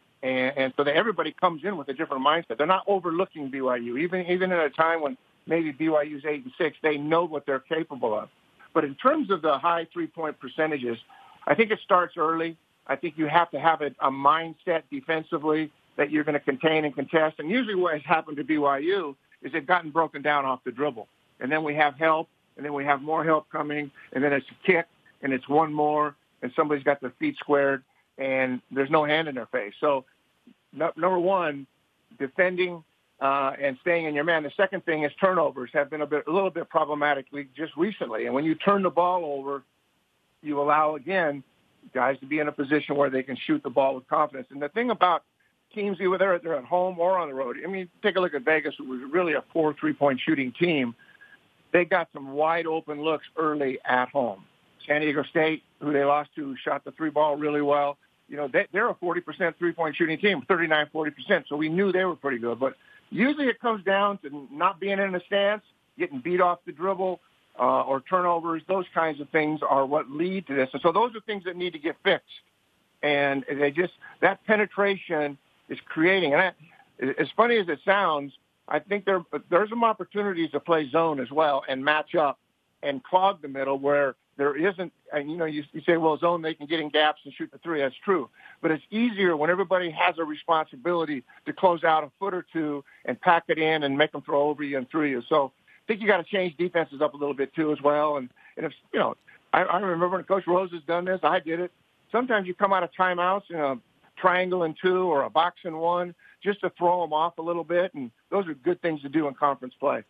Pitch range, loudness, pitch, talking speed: 145-180 Hz, -26 LUFS, 160 Hz, 225 wpm